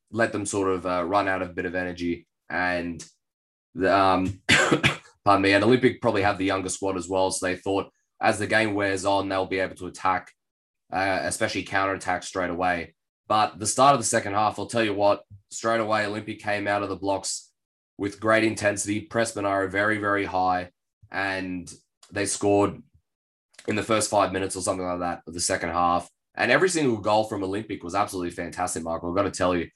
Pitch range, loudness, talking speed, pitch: 90-105 Hz, -25 LUFS, 205 wpm, 95 Hz